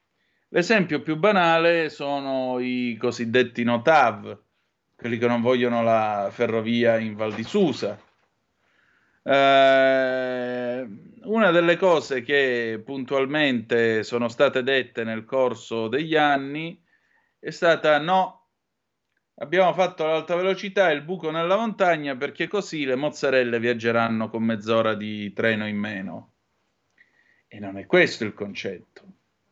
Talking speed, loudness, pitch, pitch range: 120 wpm, -22 LUFS, 130 Hz, 115-160 Hz